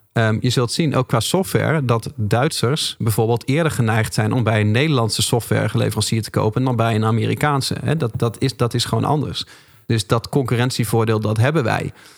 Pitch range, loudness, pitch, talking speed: 110-140 Hz, -19 LUFS, 120 Hz, 185 wpm